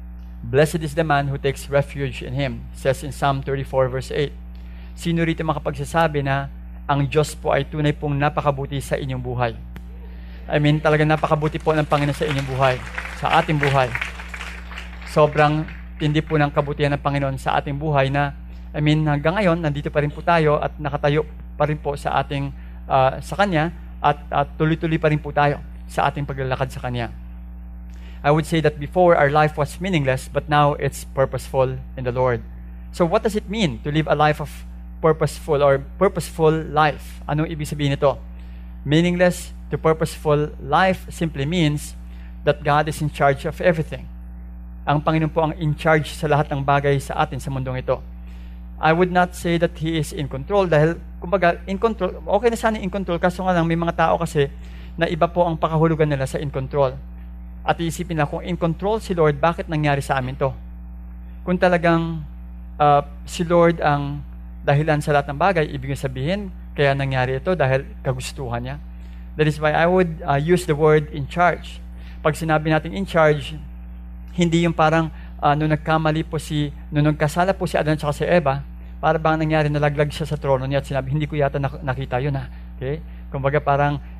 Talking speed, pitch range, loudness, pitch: 185 wpm, 130-160 Hz, -21 LUFS, 145 Hz